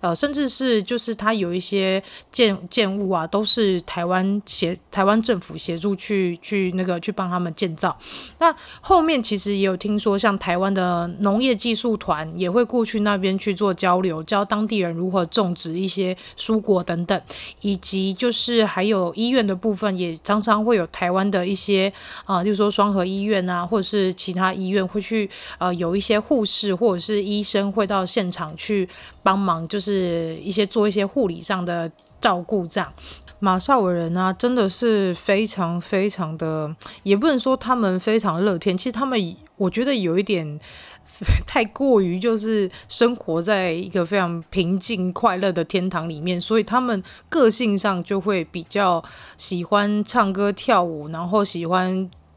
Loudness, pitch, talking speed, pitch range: -21 LUFS, 195 Hz, 260 characters per minute, 180-215 Hz